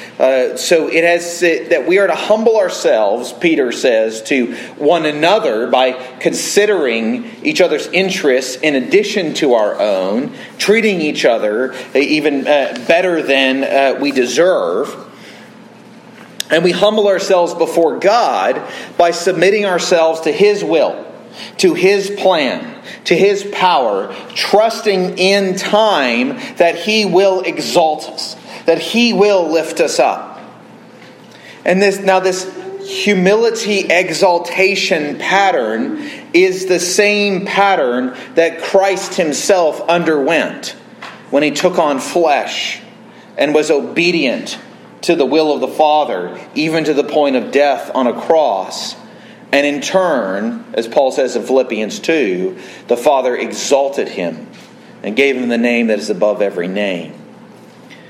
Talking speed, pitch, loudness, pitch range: 135 wpm, 185 Hz, -14 LUFS, 155-225 Hz